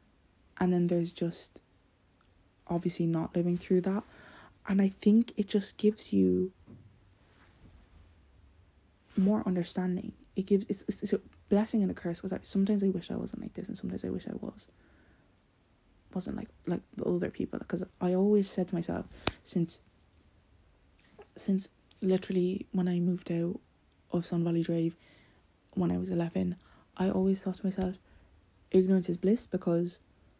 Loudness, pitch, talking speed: -32 LUFS, 175 Hz, 155 wpm